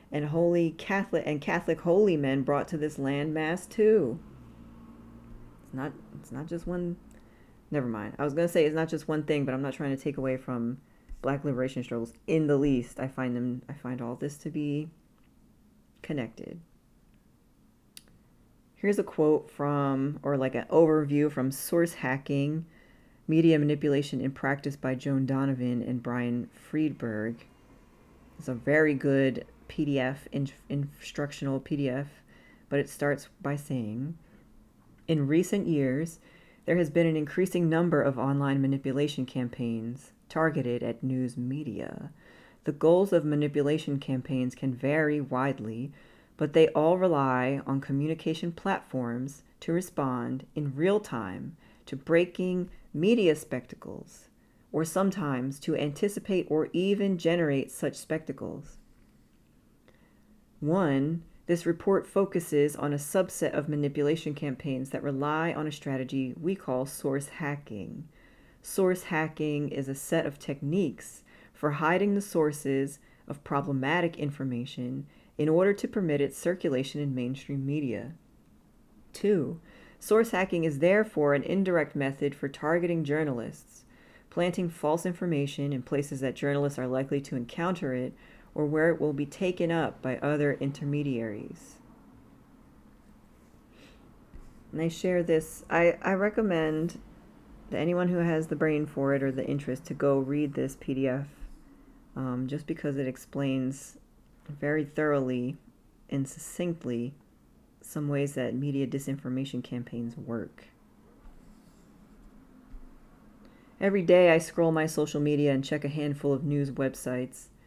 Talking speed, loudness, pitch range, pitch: 135 wpm, -29 LUFS, 135-165 Hz, 145 Hz